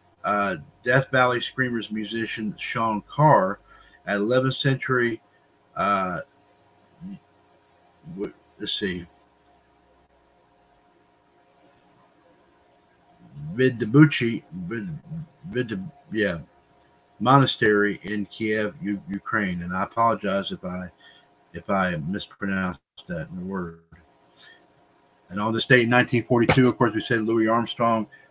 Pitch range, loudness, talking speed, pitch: 105-135 Hz, -23 LUFS, 95 wpm, 115 Hz